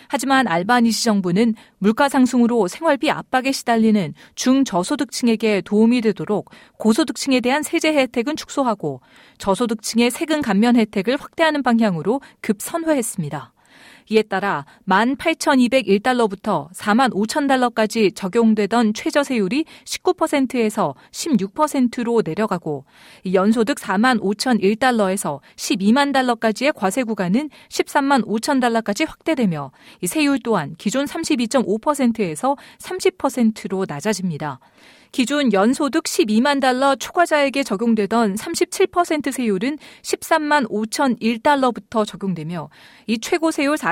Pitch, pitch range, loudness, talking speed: 240 Hz, 210-285 Hz, -19 LUFS, 255 characters per minute